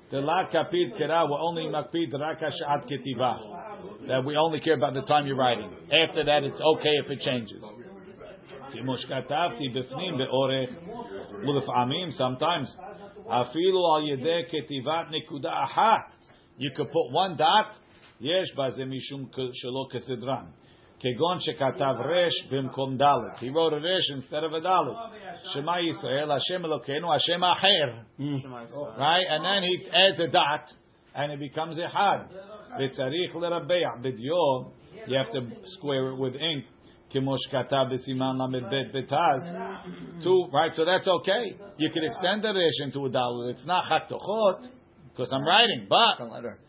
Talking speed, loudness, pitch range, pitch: 105 wpm, -26 LUFS, 130-165 Hz, 145 Hz